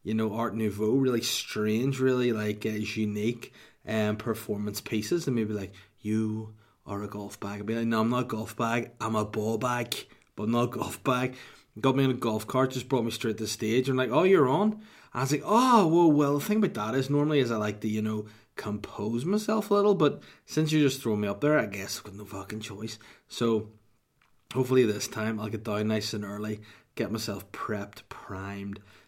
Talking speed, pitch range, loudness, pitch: 225 wpm, 105-130 Hz, -28 LUFS, 110 Hz